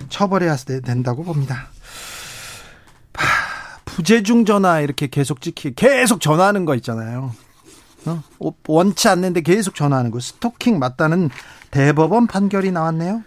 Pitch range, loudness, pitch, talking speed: 140-195 Hz, -18 LUFS, 160 Hz, 275 characters per minute